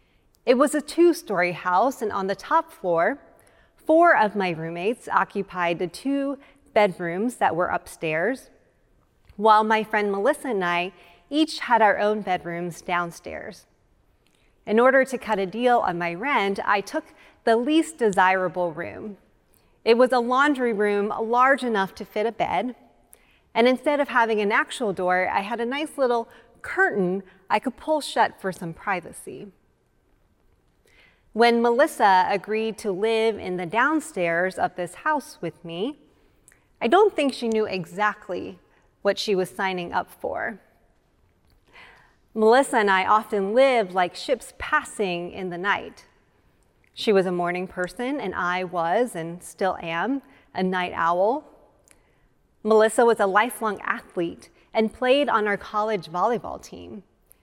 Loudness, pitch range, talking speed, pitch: -23 LUFS, 185-250 Hz, 150 wpm, 215 Hz